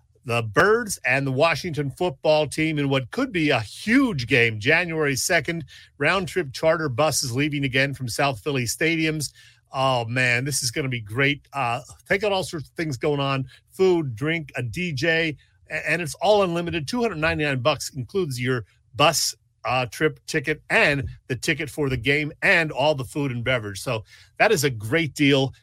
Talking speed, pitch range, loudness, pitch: 180 wpm, 130-160 Hz, -22 LUFS, 145 Hz